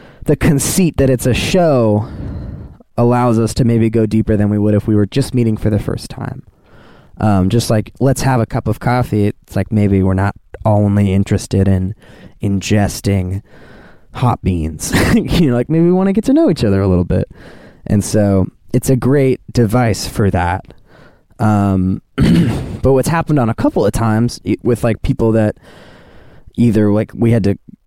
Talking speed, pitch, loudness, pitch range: 185 wpm, 110 Hz, -14 LUFS, 100-125 Hz